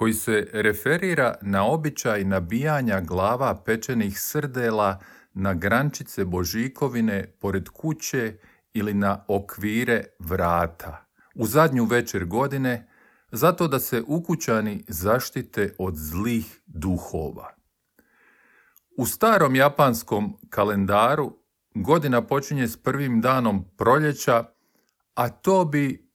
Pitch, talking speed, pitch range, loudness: 115 Hz, 100 wpm, 100-140 Hz, -24 LUFS